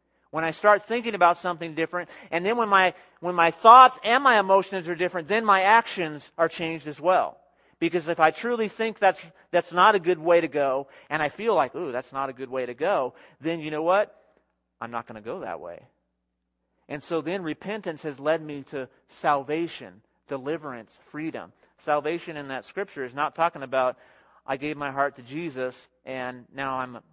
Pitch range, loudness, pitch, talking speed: 135-185 Hz, -24 LUFS, 165 Hz, 195 wpm